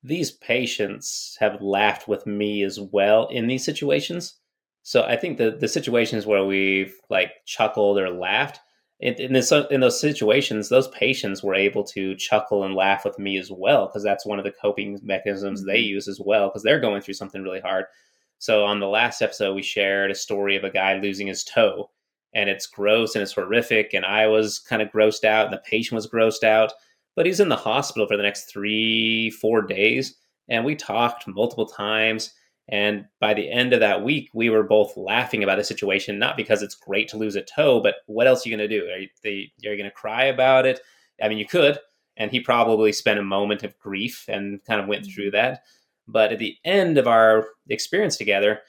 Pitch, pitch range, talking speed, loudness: 105 Hz, 100-115 Hz, 215 wpm, -22 LUFS